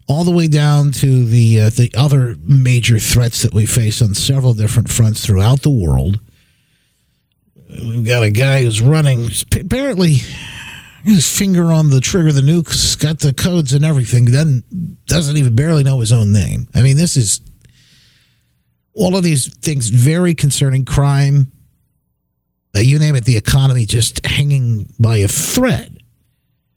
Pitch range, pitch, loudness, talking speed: 115-145 Hz, 130 Hz, -13 LUFS, 160 wpm